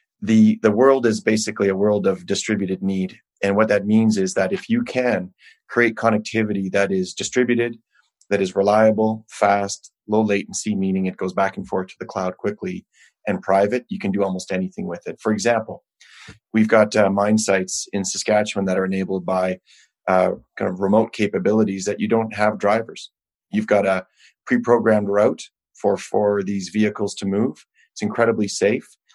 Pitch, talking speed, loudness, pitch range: 105 Hz, 175 wpm, -20 LUFS, 95-110 Hz